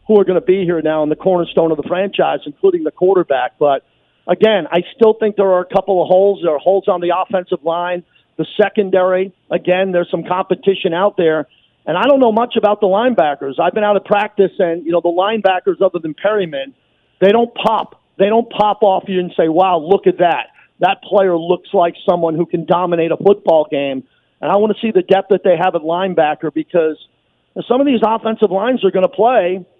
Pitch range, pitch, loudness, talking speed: 170-200 Hz, 185 Hz, -15 LUFS, 220 wpm